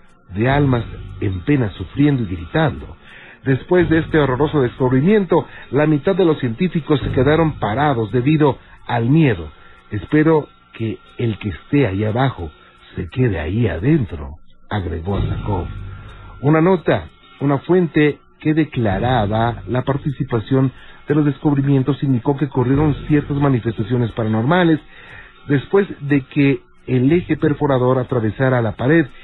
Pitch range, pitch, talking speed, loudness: 110-150 Hz, 135 Hz, 125 wpm, -18 LUFS